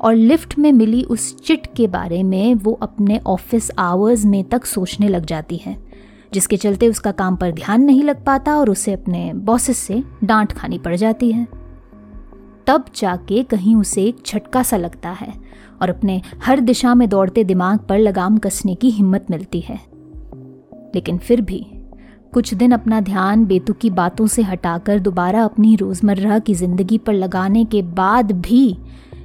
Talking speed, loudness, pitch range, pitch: 170 wpm, -16 LUFS, 190-230 Hz, 210 Hz